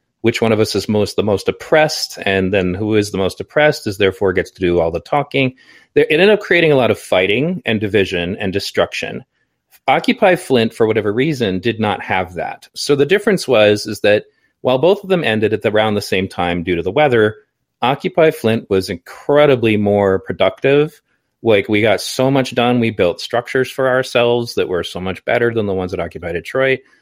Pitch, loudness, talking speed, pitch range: 115 Hz, -16 LUFS, 210 wpm, 100-145 Hz